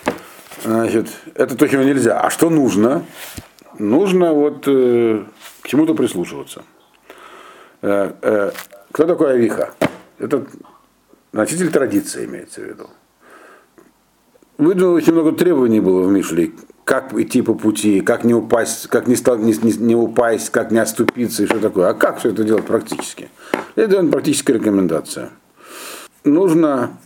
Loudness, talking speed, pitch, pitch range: -16 LUFS, 140 wpm, 115 Hz, 110-160 Hz